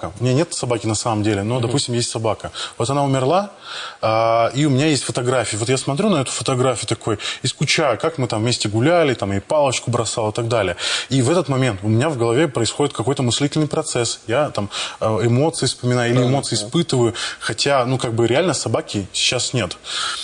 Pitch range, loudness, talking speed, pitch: 115-140 Hz, -19 LUFS, 200 wpm, 125 Hz